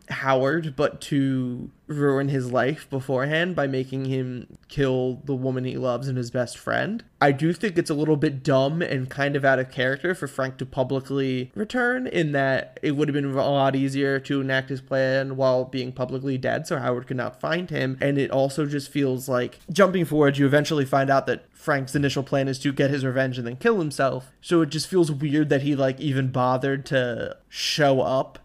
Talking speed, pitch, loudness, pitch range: 210 wpm, 135 Hz, -24 LUFS, 130-150 Hz